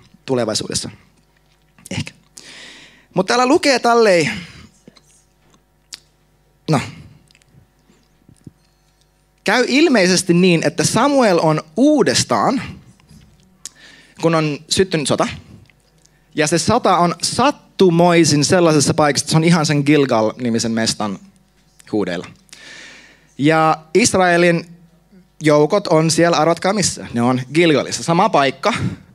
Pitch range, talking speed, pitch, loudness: 150-185 Hz, 90 wpm, 165 Hz, -15 LUFS